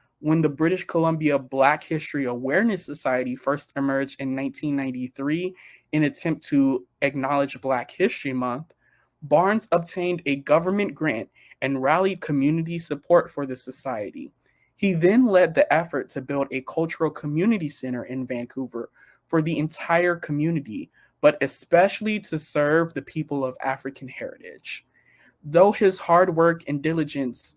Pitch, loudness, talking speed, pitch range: 145 Hz, -23 LUFS, 140 wpm, 135-170 Hz